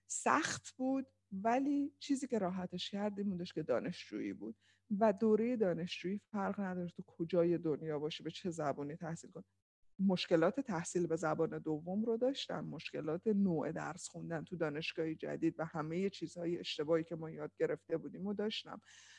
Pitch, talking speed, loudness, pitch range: 175 Hz, 160 wpm, -38 LUFS, 160-210 Hz